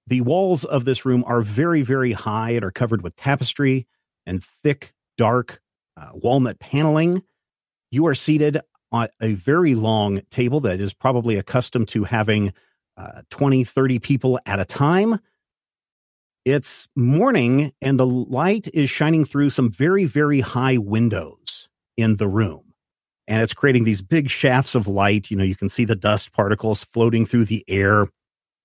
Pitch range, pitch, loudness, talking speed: 110-140 Hz, 125 Hz, -20 LUFS, 160 wpm